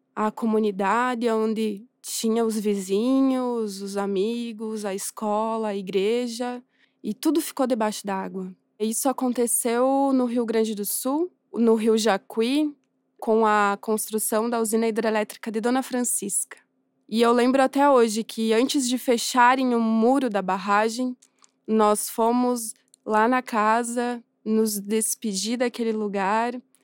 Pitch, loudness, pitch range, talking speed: 225 Hz, -23 LUFS, 215-250 Hz, 130 wpm